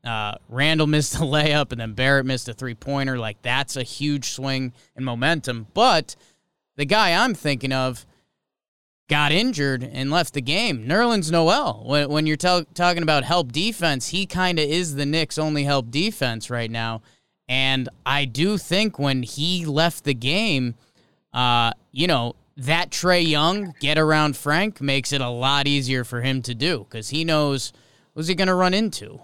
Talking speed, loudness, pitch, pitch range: 180 wpm, -21 LUFS, 145 Hz, 130-165 Hz